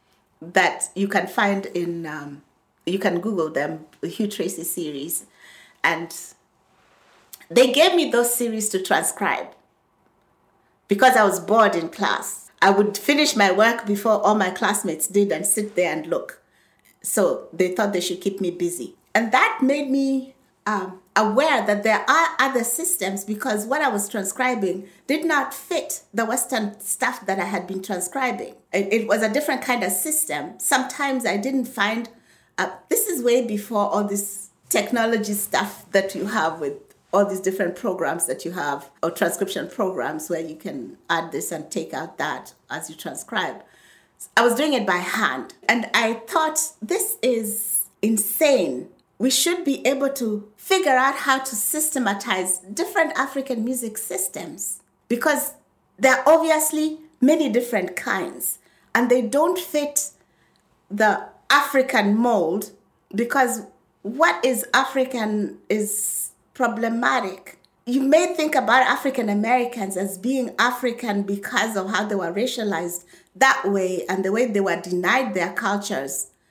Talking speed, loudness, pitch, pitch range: 150 wpm, -22 LUFS, 220 Hz, 195-265 Hz